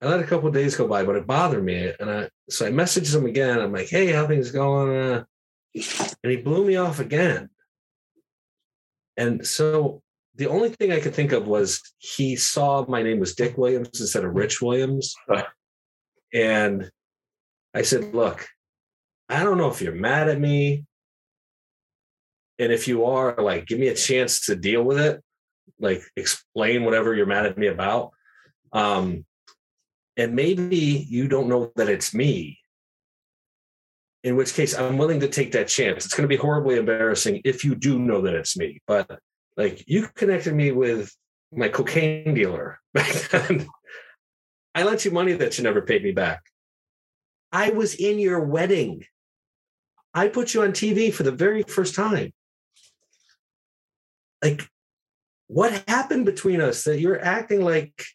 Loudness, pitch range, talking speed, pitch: -22 LUFS, 120-180 Hz, 165 wpm, 145 Hz